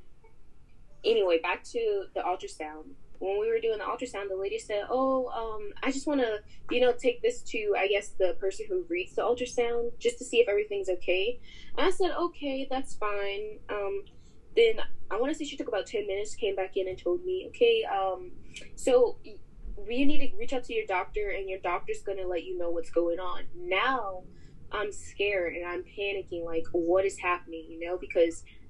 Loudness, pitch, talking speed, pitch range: -30 LUFS, 210 Hz, 200 wpm, 185-300 Hz